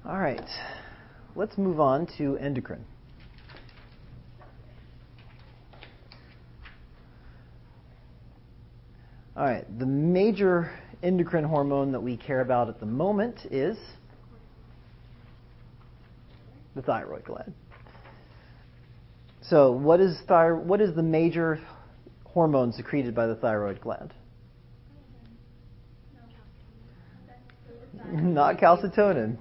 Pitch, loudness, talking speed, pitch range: 125 Hz, -26 LUFS, 80 wpm, 120-165 Hz